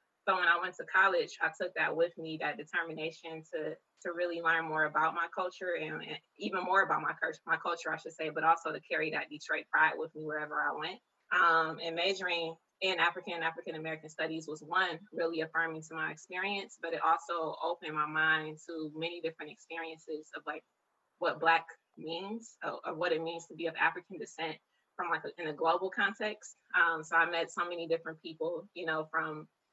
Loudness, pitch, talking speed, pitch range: -33 LUFS, 165 Hz, 205 wpm, 160-170 Hz